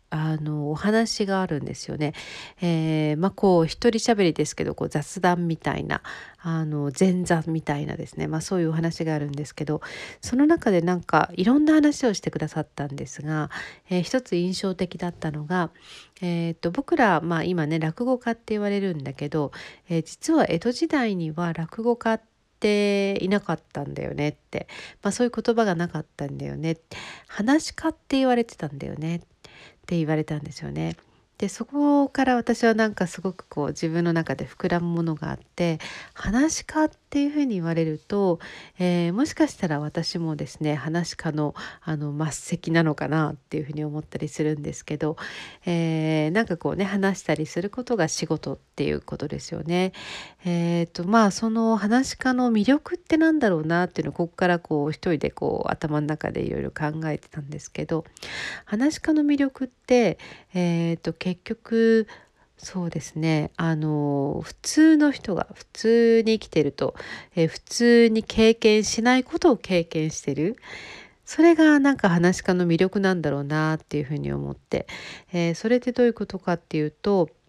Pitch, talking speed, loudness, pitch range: 175 Hz, 360 characters per minute, -24 LUFS, 155-225 Hz